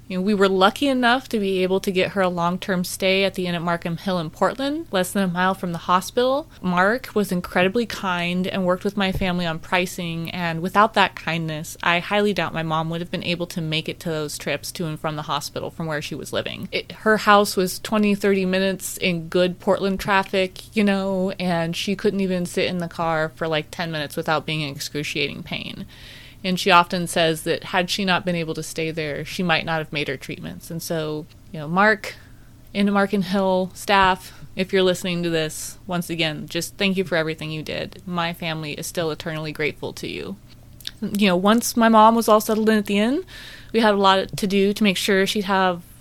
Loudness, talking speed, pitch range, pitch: -22 LUFS, 230 wpm, 165-195 Hz, 180 Hz